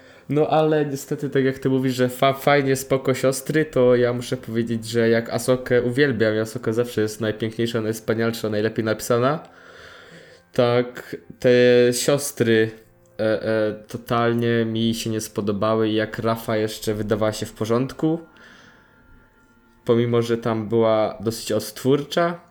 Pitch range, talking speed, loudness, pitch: 110-130 Hz, 135 wpm, -21 LUFS, 120 Hz